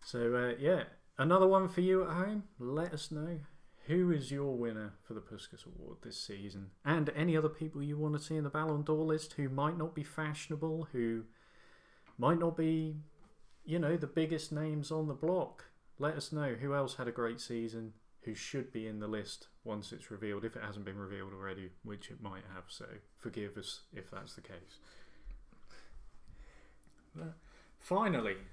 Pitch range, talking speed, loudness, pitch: 110-155 Hz, 185 wpm, -36 LUFS, 140 Hz